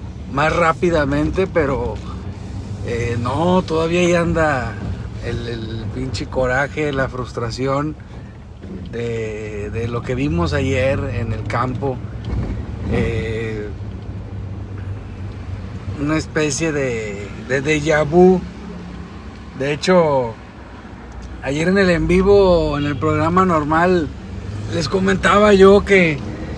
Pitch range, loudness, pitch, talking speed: 100-155 Hz, -18 LUFS, 120 Hz, 100 wpm